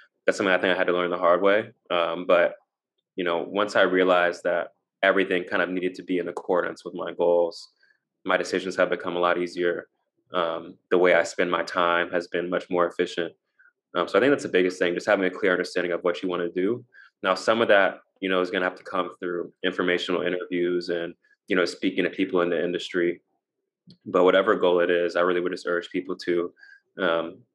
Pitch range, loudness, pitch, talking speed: 85-90 Hz, -24 LUFS, 90 Hz, 230 wpm